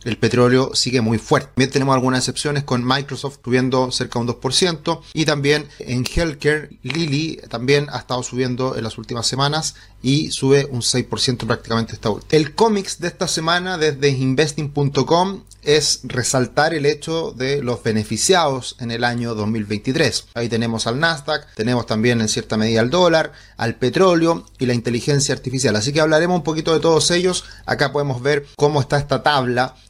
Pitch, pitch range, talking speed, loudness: 135 Hz, 120-150 Hz, 175 wpm, -19 LUFS